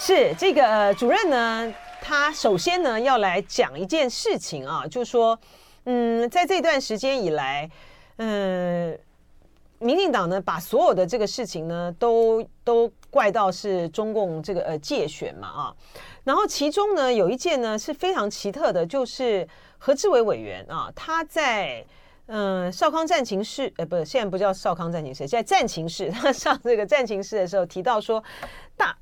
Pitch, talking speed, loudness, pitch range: 230 Hz, 250 characters per minute, -23 LUFS, 190-285 Hz